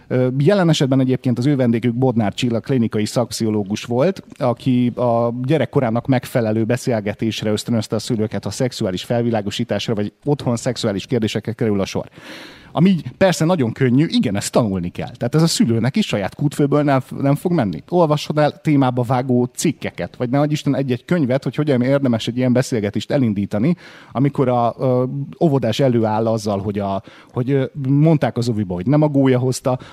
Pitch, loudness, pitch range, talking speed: 125 Hz, -18 LUFS, 110-140 Hz, 160 wpm